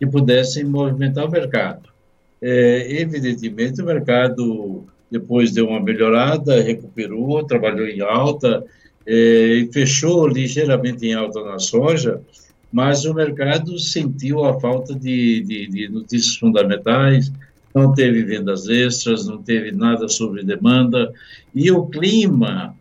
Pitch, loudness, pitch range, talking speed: 125 Hz, -17 LUFS, 115-150 Hz, 125 wpm